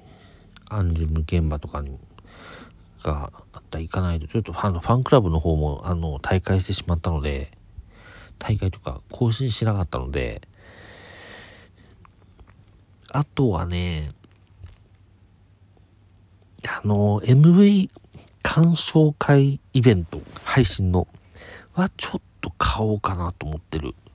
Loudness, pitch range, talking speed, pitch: -22 LUFS, 85-105 Hz, 235 characters per minute, 95 Hz